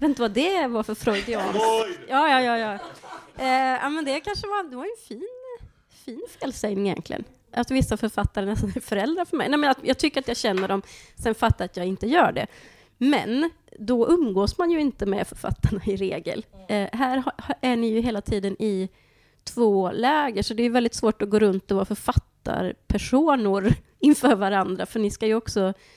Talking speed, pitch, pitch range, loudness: 210 wpm, 230 Hz, 205-275 Hz, -24 LUFS